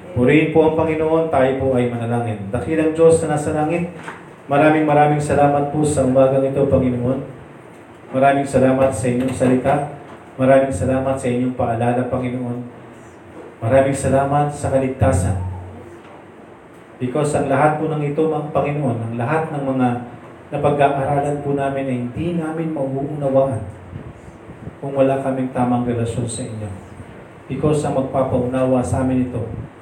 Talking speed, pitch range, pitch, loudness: 140 wpm, 125-145 Hz, 135 Hz, -18 LUFS